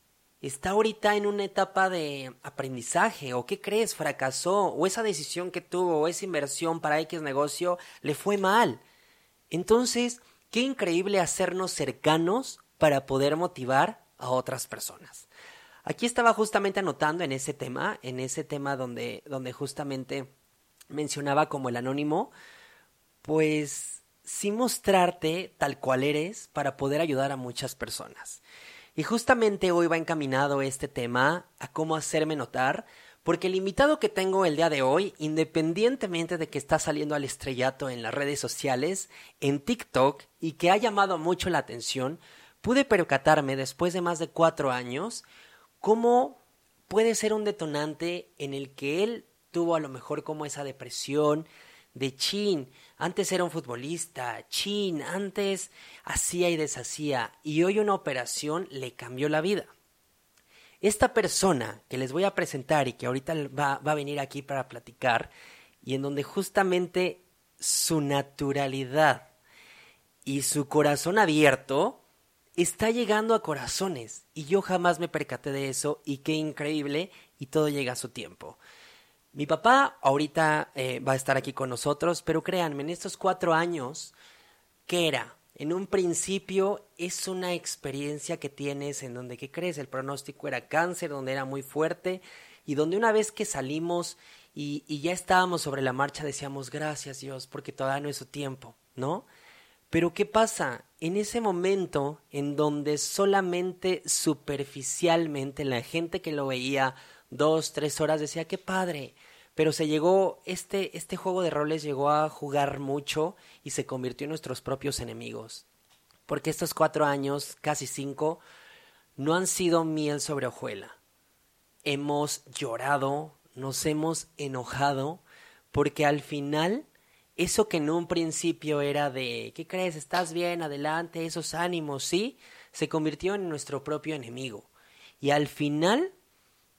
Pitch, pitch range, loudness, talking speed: 155 Hz, 140-180 Hz, -28 LUFS, 150 wpm